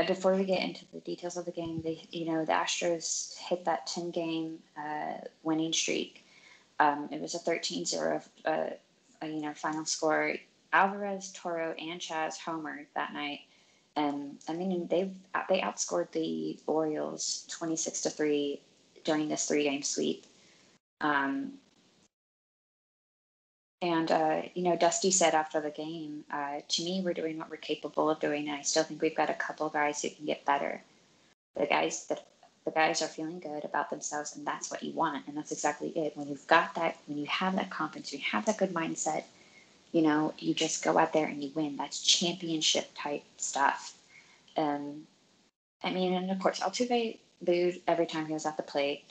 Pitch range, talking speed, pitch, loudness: 150-175 Hz, 185 wpm, 160 Hz, -32 LUFS